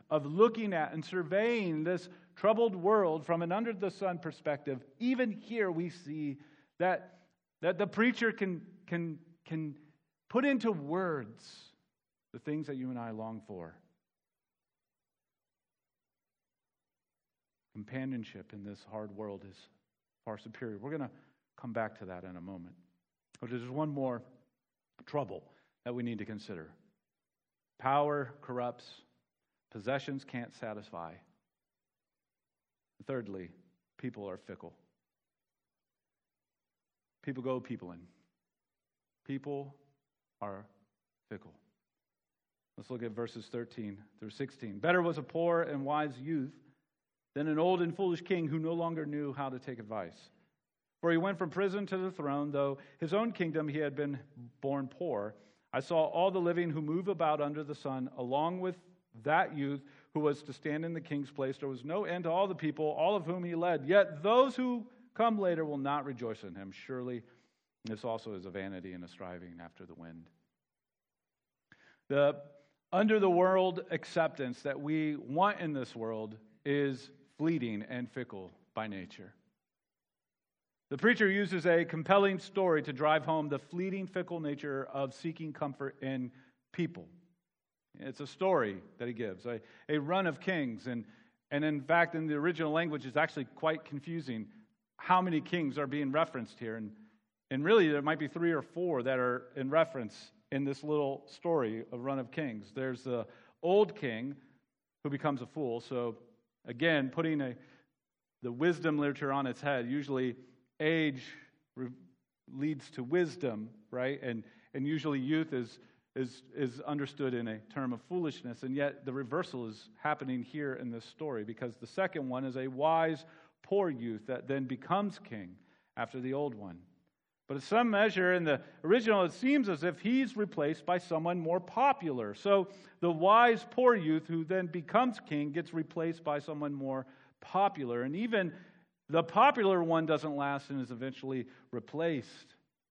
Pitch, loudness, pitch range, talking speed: 145 Hz, -34 LUFS, 125-170 Hz, 160 wpm